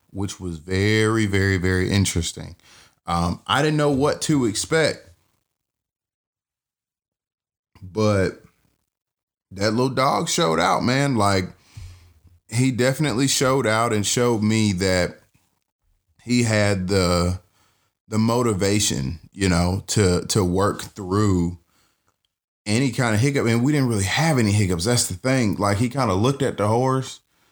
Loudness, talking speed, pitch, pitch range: -21 LUFS, 135 wpm, 105 Hz, 95-120 Hz